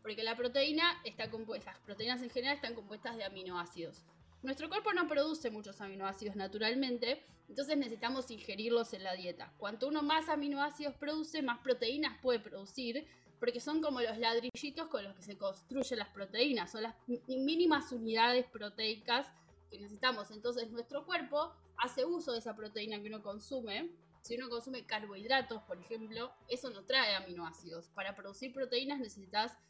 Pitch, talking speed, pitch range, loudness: 240 Hz, 160 wpm, 215-270 Hz, -38 LUFS